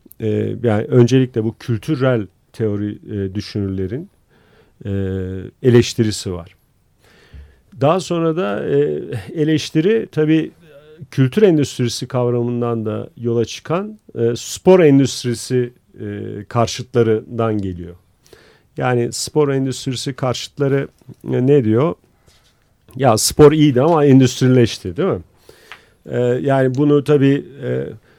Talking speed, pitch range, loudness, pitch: 100 wpm, 110-140 Hz, -17 LUFS, 125 Hz